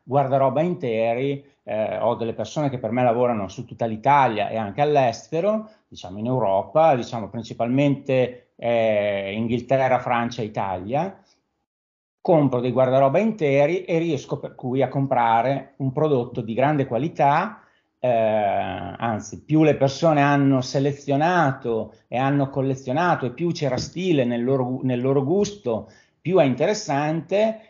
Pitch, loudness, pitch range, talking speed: 135 Hz, -22 LUFS, 115-145 Hz, 135 wpm